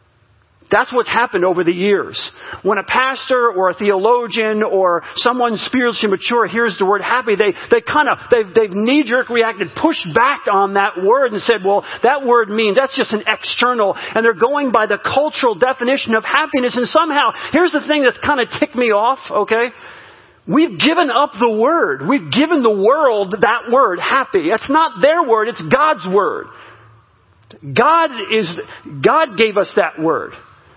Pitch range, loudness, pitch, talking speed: 205-280 Hz, -15 LUFS, 235 Hz, 175 wpm